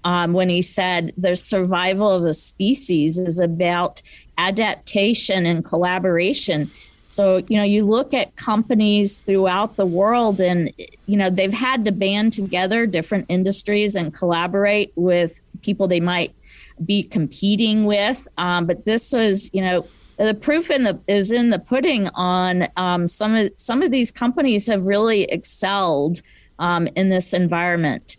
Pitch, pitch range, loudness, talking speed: 190 Hz, 175-210 Hz, -18 LUFS, 155 wpm